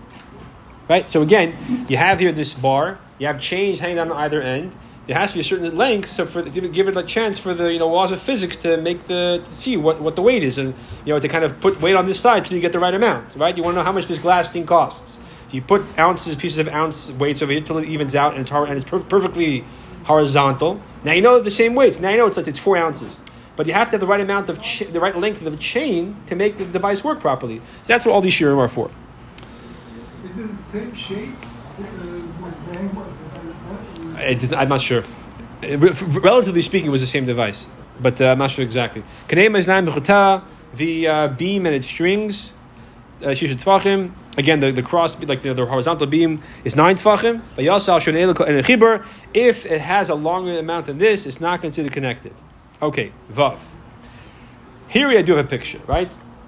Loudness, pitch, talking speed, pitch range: -18 LUFS, 170 Hz, 215 wpm, 145-195 Hz